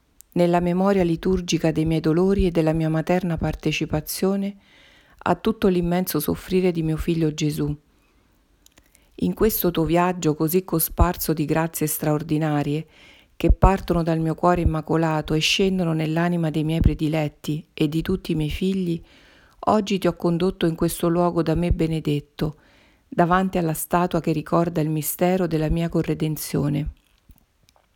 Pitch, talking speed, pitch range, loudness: 165 Hz, 140 wpm, 155-180 Hz, -22 LUFS